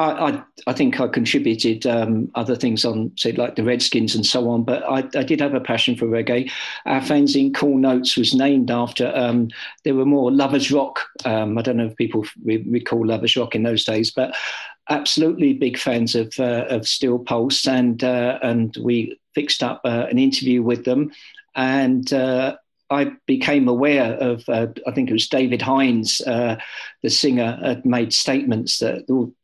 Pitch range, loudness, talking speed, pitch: 115-135 Hz, -19 LUFS, 190 wpm, 125 Hz